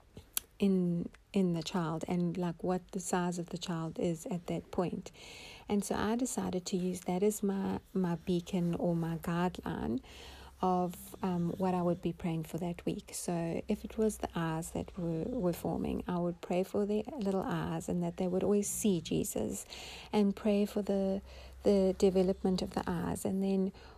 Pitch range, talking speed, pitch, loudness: 175-200 Hz, 190 wpm, 185 Hz, -34 LUFS